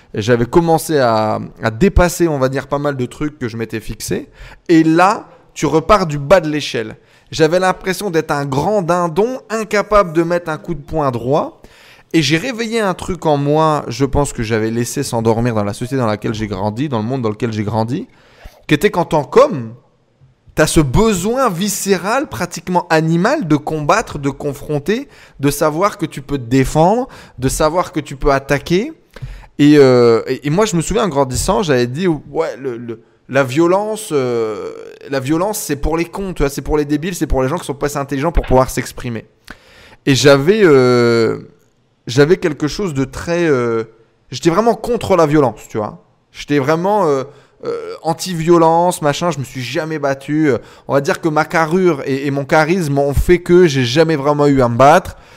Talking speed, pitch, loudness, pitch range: 200 wpm, 150 Hz, -15 LUFS, 130-175 Hz